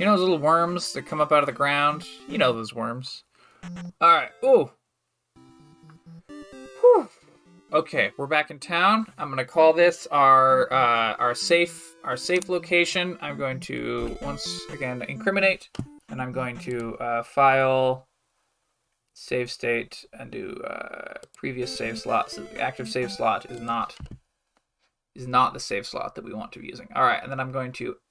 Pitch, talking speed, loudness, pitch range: 135 Hz, 175 wpm, -23 LUFS, 125-170 Hz